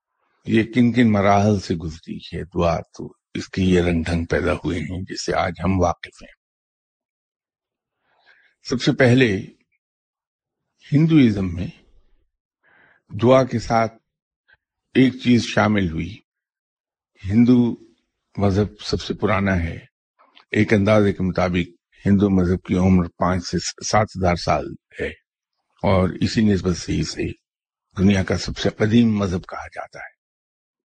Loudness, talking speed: -20 LUFS, 130 wpm